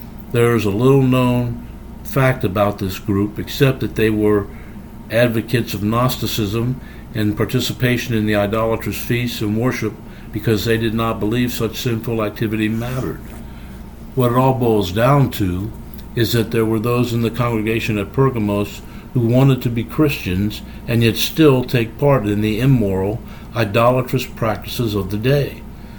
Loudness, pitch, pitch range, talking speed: -18 LUFS, 115 Hz, 105-125 Hz, 155 wpm